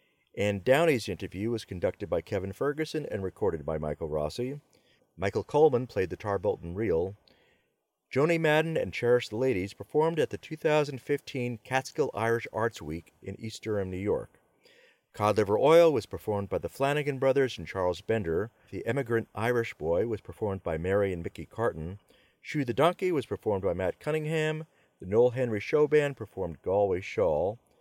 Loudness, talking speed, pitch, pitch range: -29 LUFS, 165 wpm, 120 Hz, 100-150 Hz